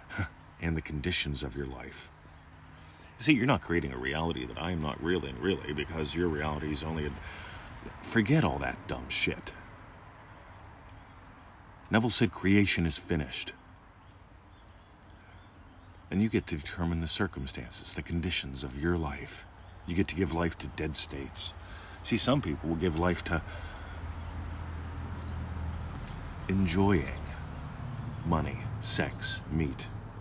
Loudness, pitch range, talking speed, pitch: -31 LUFS, 80-95 Hz, 130 wpm, 85 Hz